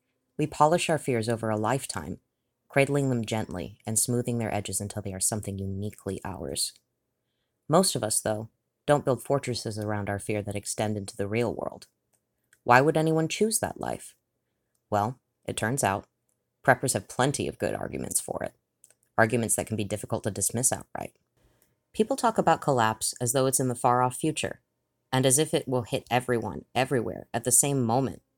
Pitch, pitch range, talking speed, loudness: 120 Hz, 105-130 Hz, 180 wpm, -27 LUFS